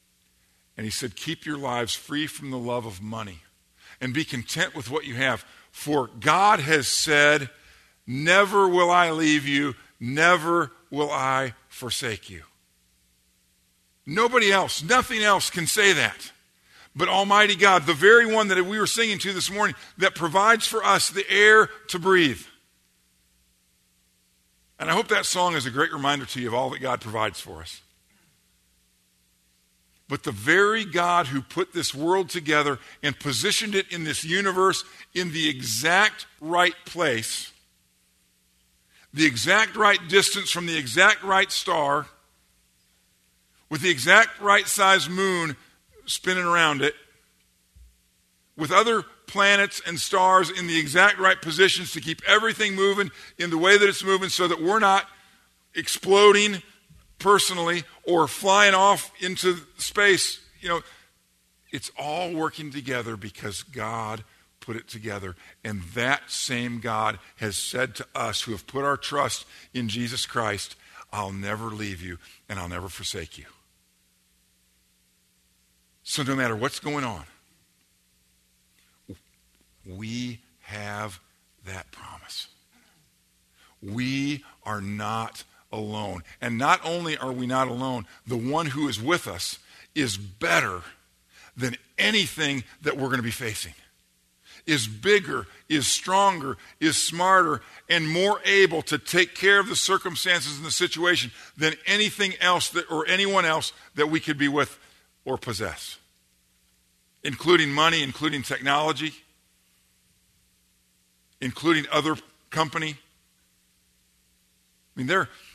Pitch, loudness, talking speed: 145 Hz, -22 LUFS, 135 wpm